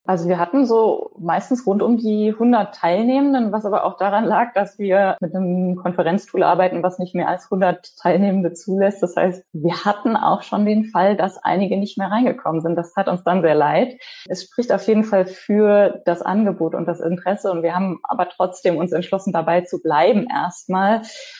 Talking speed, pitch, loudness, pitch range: 195 wpm, 190 Hz, -19 LUFS, 180-215 Hz